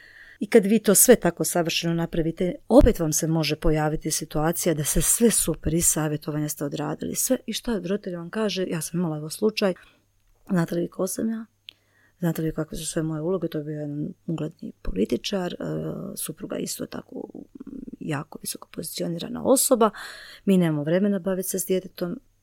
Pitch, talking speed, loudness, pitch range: 170 Hz, 185 wpm, -24 LUFS, 155-200 Hz